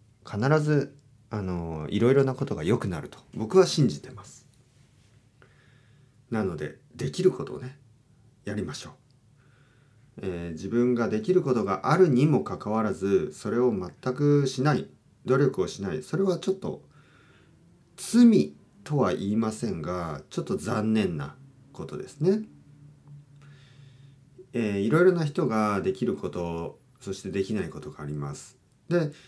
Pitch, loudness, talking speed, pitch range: 130 Hz, -26 LUFS, 260 characters per minute, 110-145 Hz